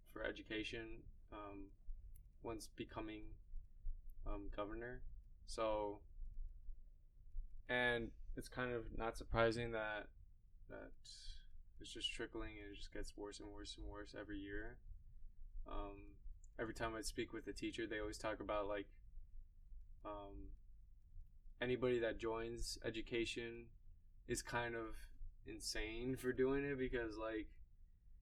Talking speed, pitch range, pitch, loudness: 120 wpm, 85-115 Hz, 105 Hz, -46 LUFS